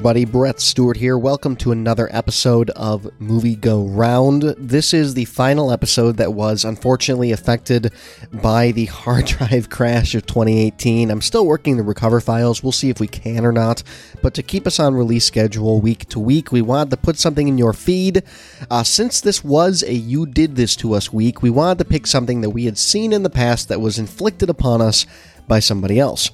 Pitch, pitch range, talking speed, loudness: 120 Hz, 110-140 Hz, 205 wpm, -16 LUFS